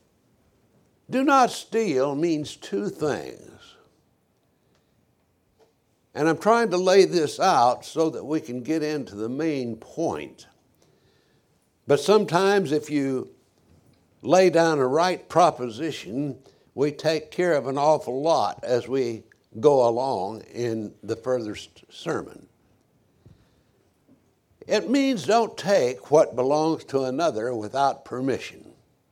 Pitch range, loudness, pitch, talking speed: 125-175 Hz, -23 LUFS, 150 Hz, 115 wpm